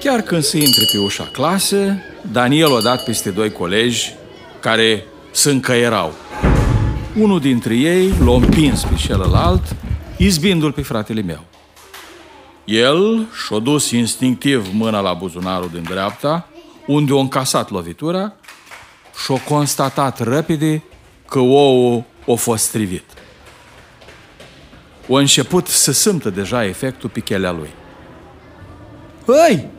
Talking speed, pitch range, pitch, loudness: 115 wpm, 105-150 Hz, 125 Hz, -16 LUFS